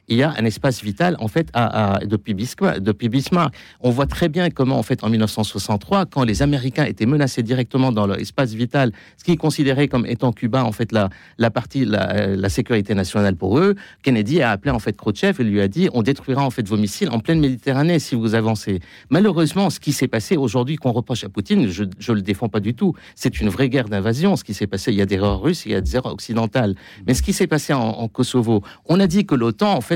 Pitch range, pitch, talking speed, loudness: 110-145 Hz, 120 Hz, 250 wpm, -19 LUFS